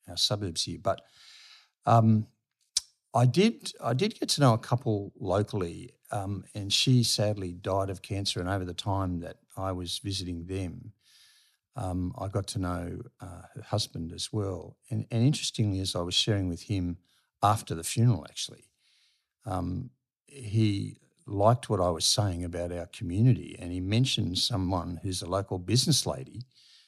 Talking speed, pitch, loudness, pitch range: 165 wpm, 100 Hz, -29 LUFS, 90-120 Hz